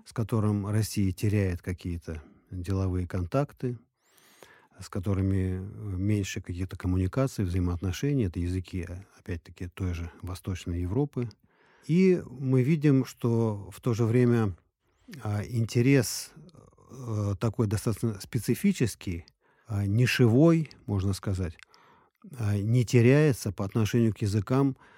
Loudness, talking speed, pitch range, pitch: -28 LUFS, 110 wpm, 95-125 Hz, 105 Hz